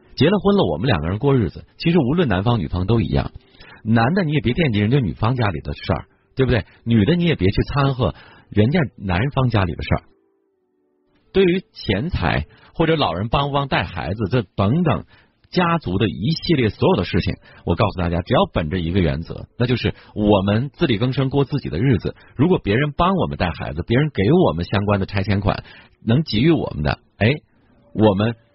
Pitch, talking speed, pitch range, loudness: 115 Hz, 305 characters per minute, 95-140 Hz, -20 LUFS